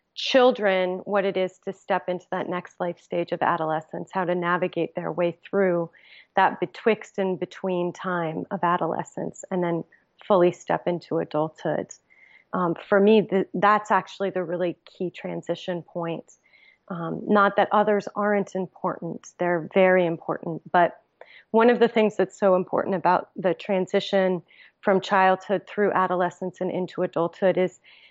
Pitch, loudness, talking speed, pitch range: 185 Hz, -24 LUFS, 150 wpm, 175-195 Hz